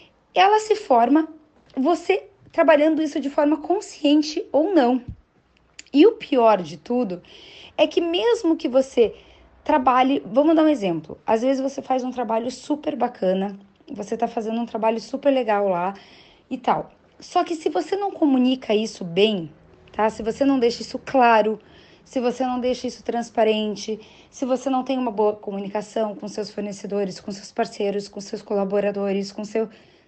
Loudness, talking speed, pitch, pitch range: -22 LUFS, 165 wpm, 245 Hz, 210-300 Hz